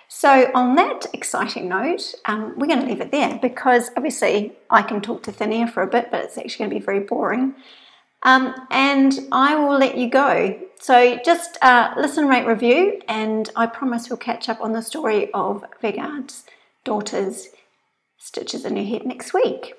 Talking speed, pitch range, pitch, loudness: 190 wpm, 230-280 Hz, 255 Hz, -19 LUFS